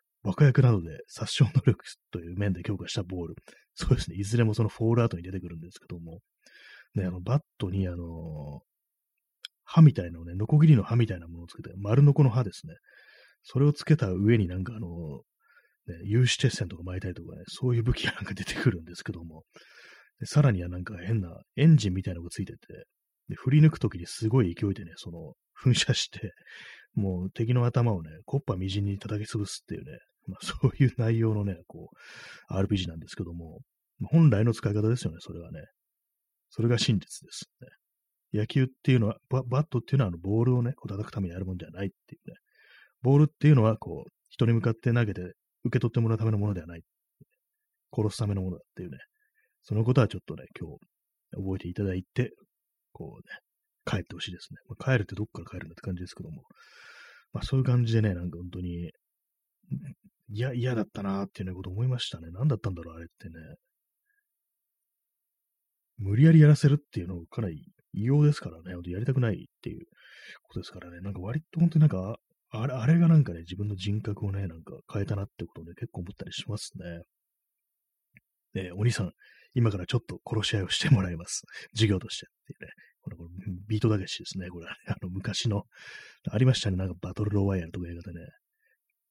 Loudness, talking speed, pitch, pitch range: -27 LUFS, 420 characters per minute, 105 Hz, 90-130 Hz